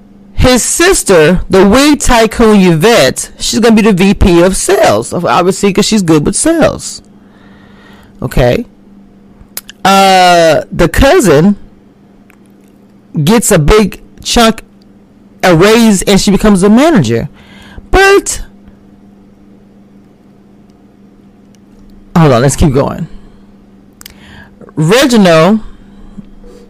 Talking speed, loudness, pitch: 90 wpm, -7 LUFS, 190 Hz